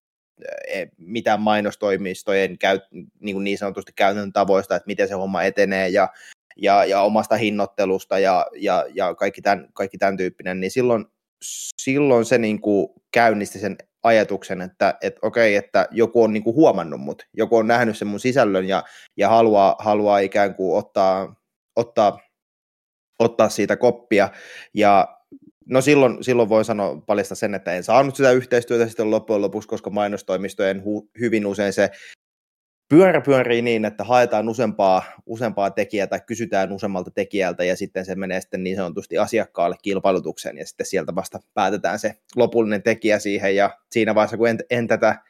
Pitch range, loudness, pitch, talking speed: 95-115 Hz, -20 LUFS, 105 Hz, 160 wpm